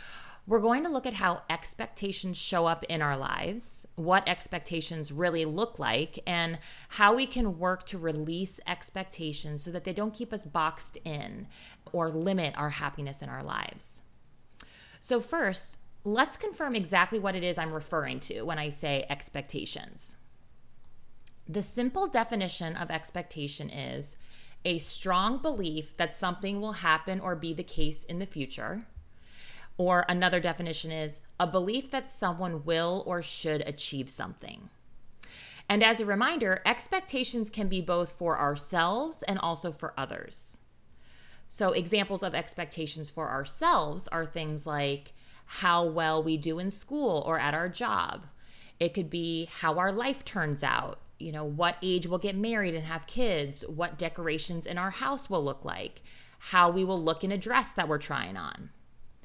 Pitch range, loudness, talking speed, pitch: 155-195 Hz, -30 LUFS, 160 wpm, 175 Hz